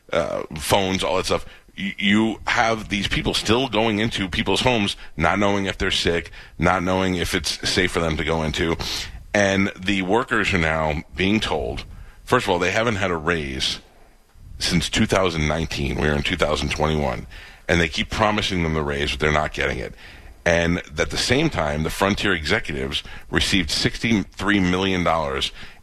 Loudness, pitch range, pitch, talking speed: -21 LUFS, 80-100 Hz, 90 Hz, 170 wpm